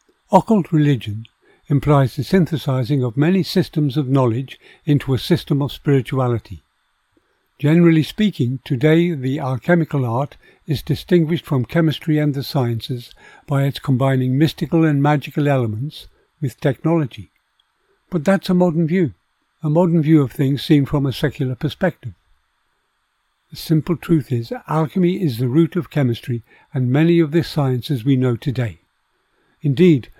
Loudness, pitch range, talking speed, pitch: -18 LUFS, 130-165 Hz, 140 wpm, 145 Hz